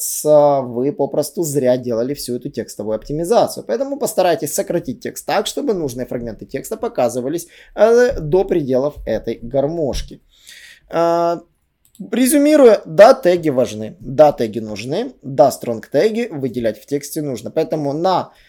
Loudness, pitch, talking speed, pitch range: -17 LUFS, 145 Hz, 125 wpm, 125-175 Hz